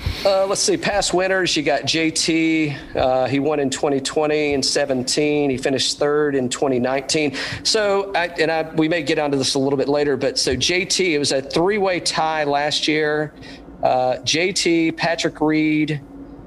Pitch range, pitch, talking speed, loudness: 140-165 Hz, 155 Hz, 175 wpm, -19 LUFS